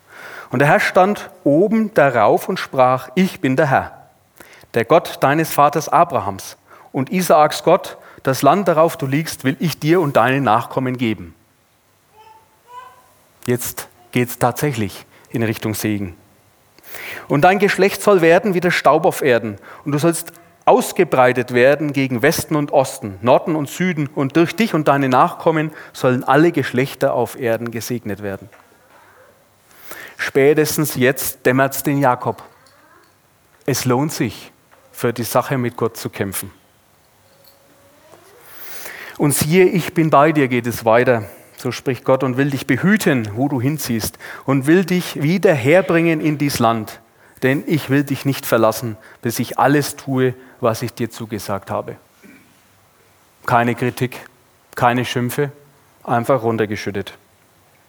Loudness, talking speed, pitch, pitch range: -17 LUFS, 145 wpm, 135 Hz, 115-155 Hz